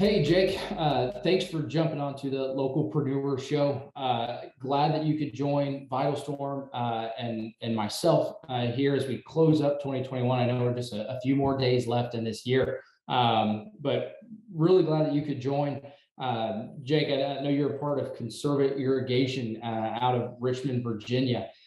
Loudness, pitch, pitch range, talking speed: -28 LUFS, 135 Hz, 125-145 Hz, 185 wpm